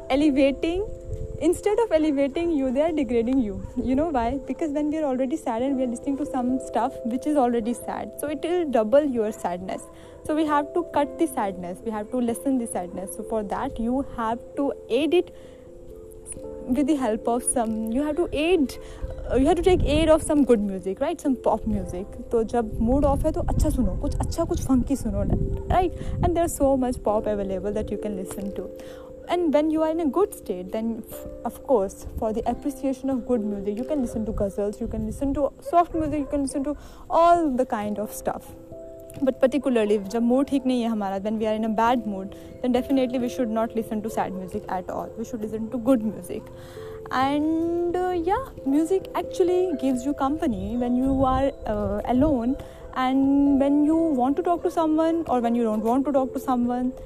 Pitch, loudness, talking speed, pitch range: 260 Hz, -24 LUFS, 200 wpm, 230-300 Hz